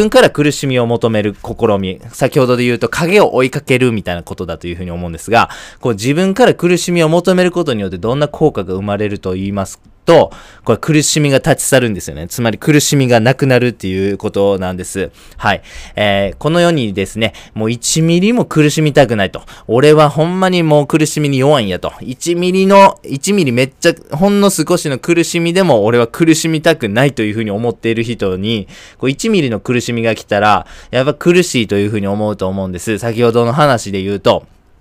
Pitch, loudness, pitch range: 120 Hz, -13 LUFS, 100-155 Hz